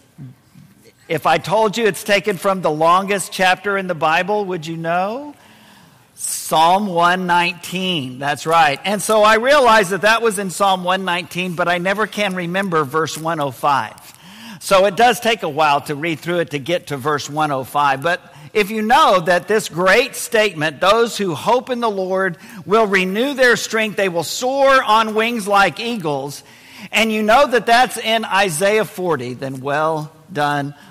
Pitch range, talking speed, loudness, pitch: 160-215 Hz, 170 wpm, -16 LUFS, 190 Hz